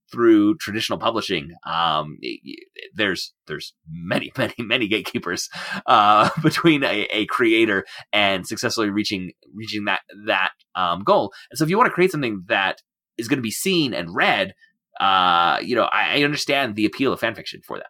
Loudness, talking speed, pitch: -20 LUFS, 180 wpm, 150 Hz